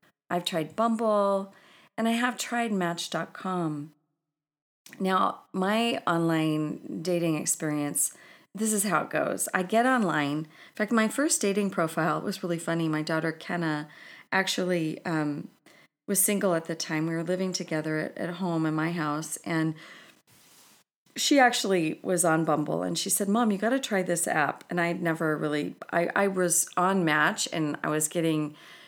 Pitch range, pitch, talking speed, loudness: 155-200 Hz, 170 Hz, 160 wpm, -27 LUFS